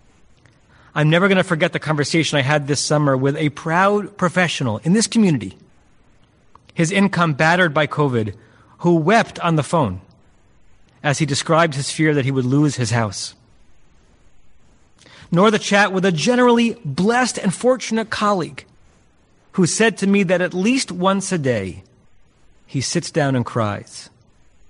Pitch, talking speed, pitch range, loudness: 155 Hz, 155 wpm, 125-190 Hz, -18 LUFS